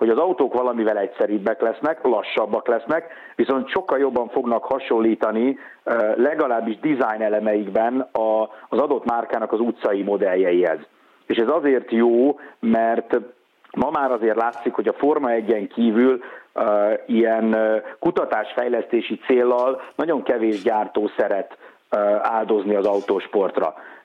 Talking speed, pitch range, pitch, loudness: 115 wpm, 110-125 Hz, 115 Hz, -21 LUFS